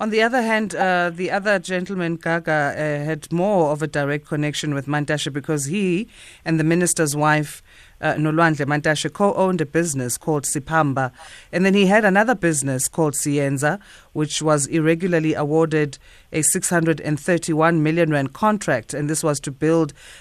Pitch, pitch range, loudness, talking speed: 160 Hz, 150-175 Hz, -20 LUFS, 165 wpm